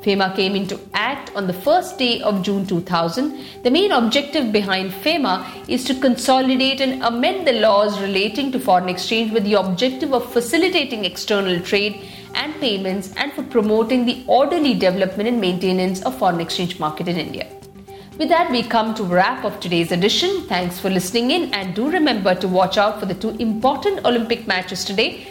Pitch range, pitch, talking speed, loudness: 190-260 Hz, 210 Hz, 180 wpm, -19 LUFS